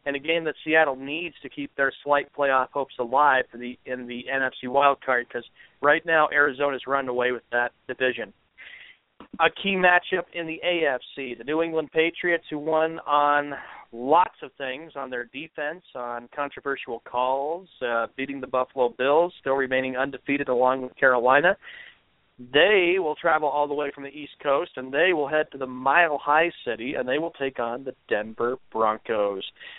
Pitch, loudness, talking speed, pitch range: 140 Hz, -24 LUFS, 175 wpm, 130-155 Hz